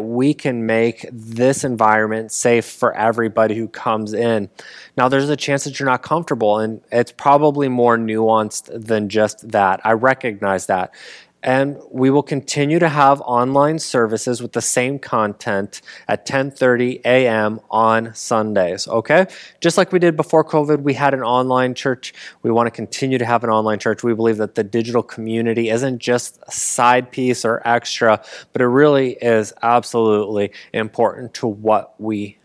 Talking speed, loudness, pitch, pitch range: 165 wpm, -17 LUFS, 120 Hz, 110-135 Hz